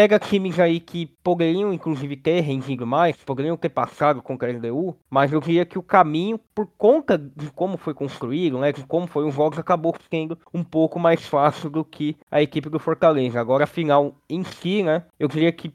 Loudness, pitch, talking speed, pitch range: -22 LUFS, 160 Hz, 200 wpm, 145-175 Hz